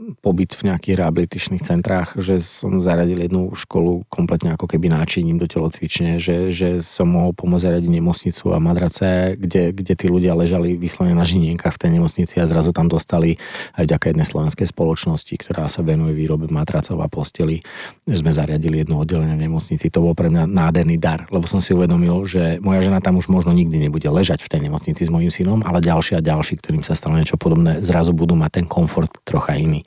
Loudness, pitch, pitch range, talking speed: -18 LUFS, 85 Hz, 80-90 Hz, 205 wpm